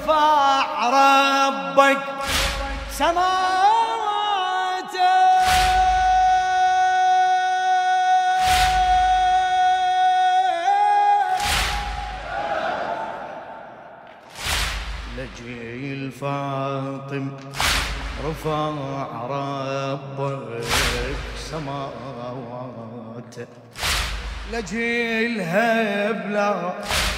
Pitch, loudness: 275 Hz, -20 LUFS